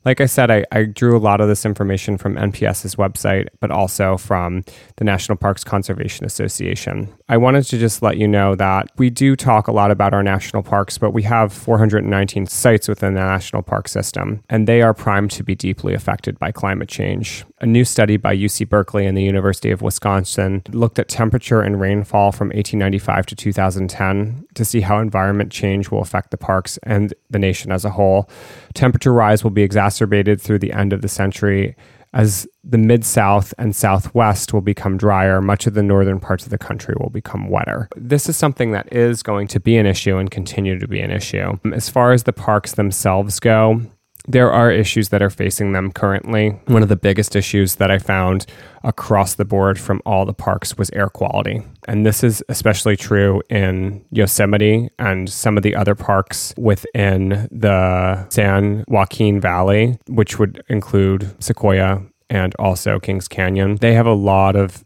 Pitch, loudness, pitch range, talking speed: 105 Hz, -17 LUFS, 95-110 Hz, 190 wpm